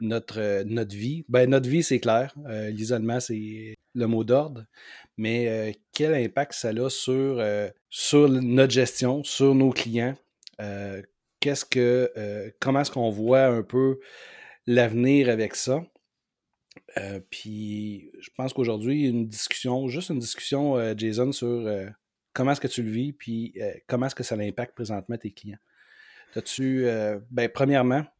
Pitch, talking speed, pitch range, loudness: 120 Hz, 160 wpm, 110-135 Hz, -25 LUFS